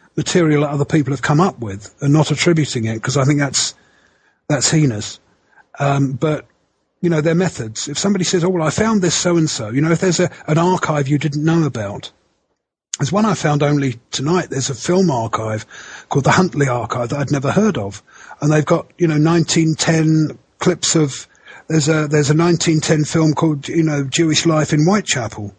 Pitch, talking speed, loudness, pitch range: 155 Hz, 200 wpm, -16 LUFS, 140-165 Hz